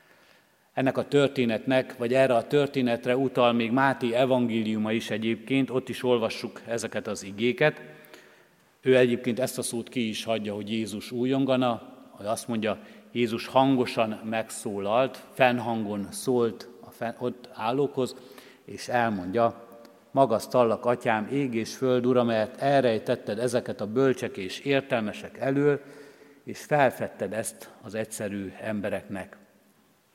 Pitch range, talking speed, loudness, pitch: 115-130 Hz, 130 wpm, -27 LUFS, 120 Hz